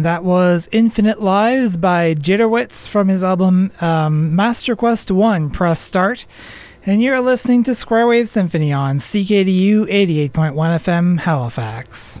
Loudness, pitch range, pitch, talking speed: -15 LUFS, 165-220 Hz, 190 Hz, 135 wpm